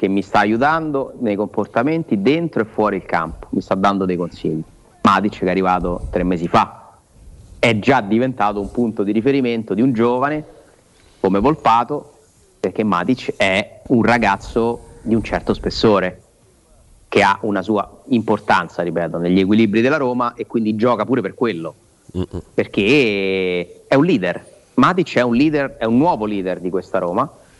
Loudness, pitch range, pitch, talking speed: -18 LUFS, 95-120 Hz, 105 Hz, 165 wpm